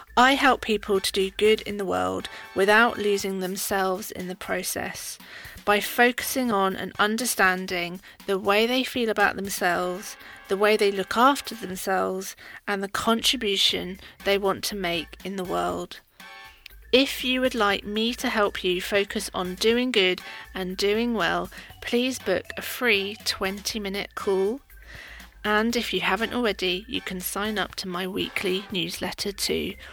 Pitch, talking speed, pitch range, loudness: 200 Hz, 155 wpm, 185-225 Hz, -24 LUFS